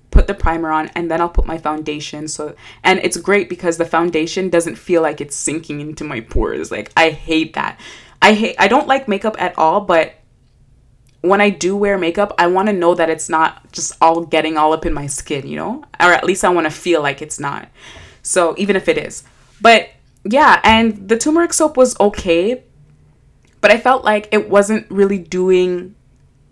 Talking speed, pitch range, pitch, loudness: 205 wpm, 155-200 Hz, 170 Hz, -15 LUFS